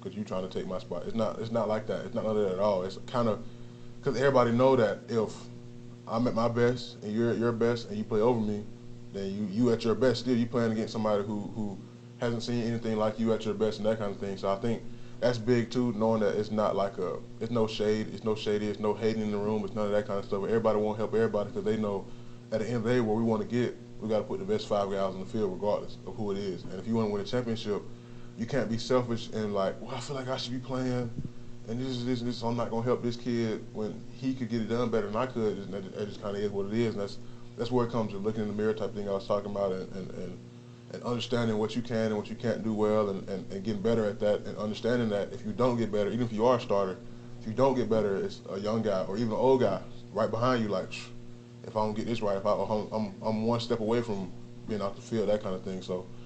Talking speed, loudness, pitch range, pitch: 300 wpm, -31 LUFS, 105-120 Hz, 115 Hz